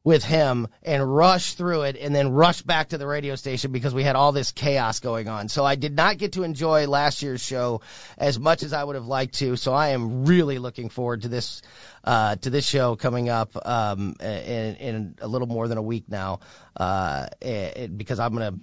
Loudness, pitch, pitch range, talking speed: -24 LUFS, 135 Hz, 115-145 Hz, 225 wpm